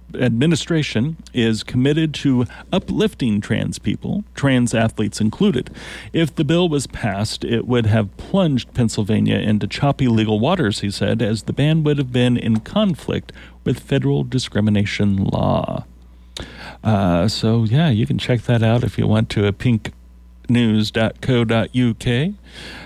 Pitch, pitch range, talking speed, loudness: 115 Hz, 105-140 Hz, 140 wpm, -19 LUFS